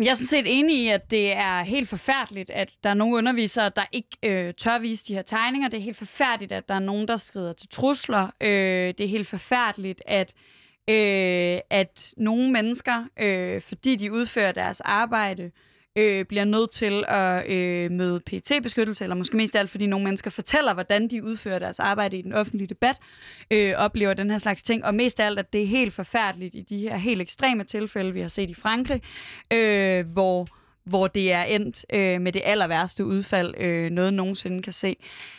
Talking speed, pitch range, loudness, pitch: 205 wpm, 190-225 Hz, -24 LUFS, 205 Hz